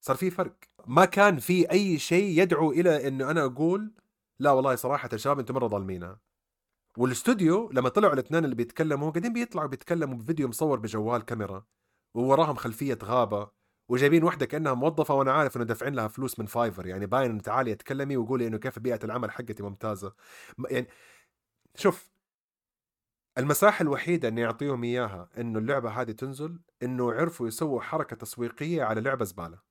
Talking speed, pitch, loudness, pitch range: 160 wpm, 130 Hz, -27 LUFS, 115-160 Hz